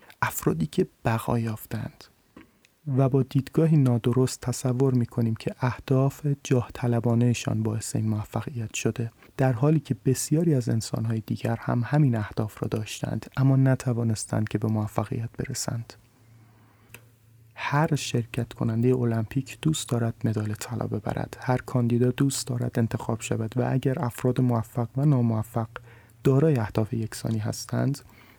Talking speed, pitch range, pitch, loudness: 130 wpm, 115-130 Hz, 120 Hz, -26 LUFS